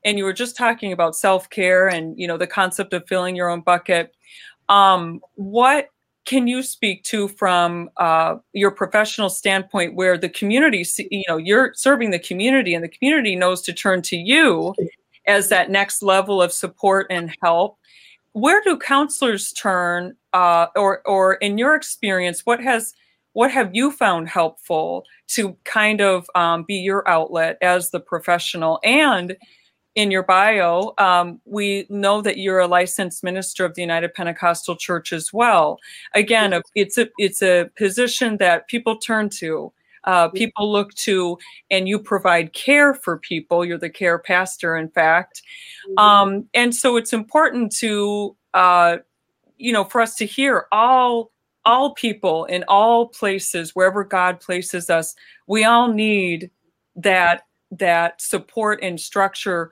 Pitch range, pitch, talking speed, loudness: 175-220 Hz, 195 Hz, 160 wpm, -18 LUFS